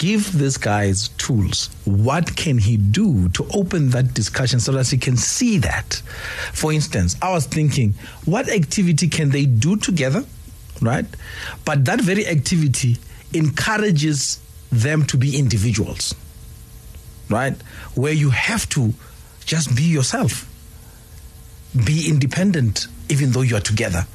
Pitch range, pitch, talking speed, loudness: 105-155 Hz, 130 Hz, 135 wpm, -19 LUFS